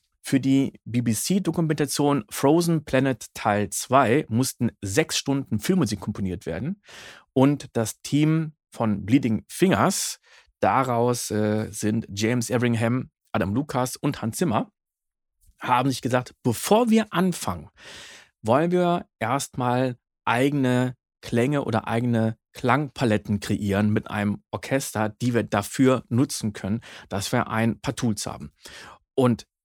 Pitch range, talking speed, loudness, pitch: 110-140 Hz, 120 wpm, -24 LUFS, 120 Hz